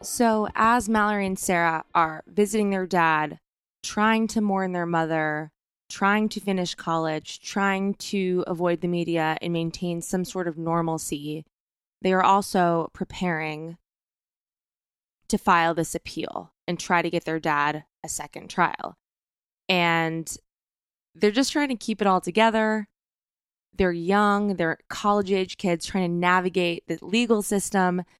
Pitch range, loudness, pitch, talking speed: 165-205 Hz, -24 LUFS, 180 Hz, 145 wpm